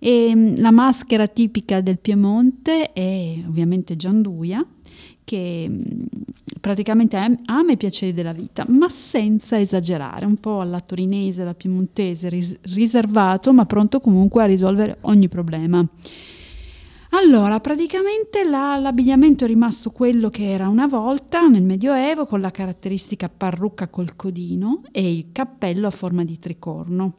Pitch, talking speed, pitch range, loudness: 210 Hz, 130 wpm, 185-245 Hz, -18 LUFS